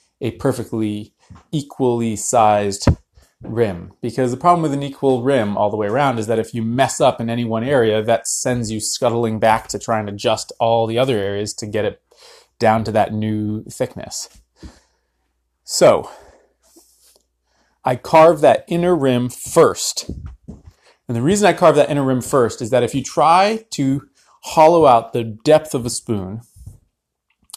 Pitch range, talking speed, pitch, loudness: 110-140 Hz, 165 wpm, 115 Hz, -17 LUFS